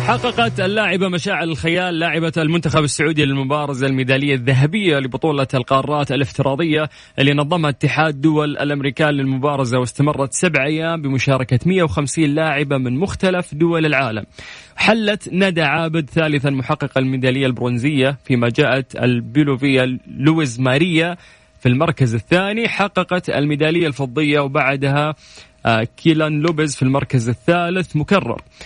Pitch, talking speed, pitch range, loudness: 150 Hz, 115 wpm, 135-165 Hz, -17 LUFS